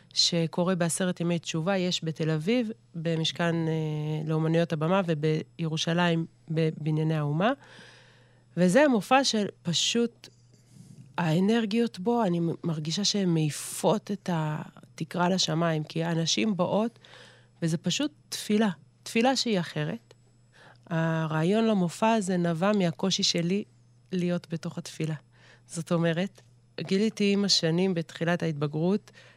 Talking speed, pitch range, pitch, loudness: 105 wpm, 155-190 Hz, 170 Hz, -27 LUFS